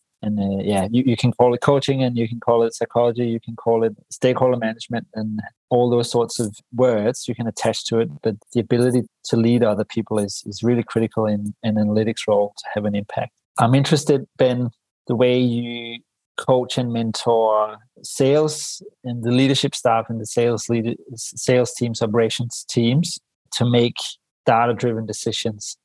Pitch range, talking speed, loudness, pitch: 115-125 Hz, 180 wpm, -20 LUFS, 120 Hz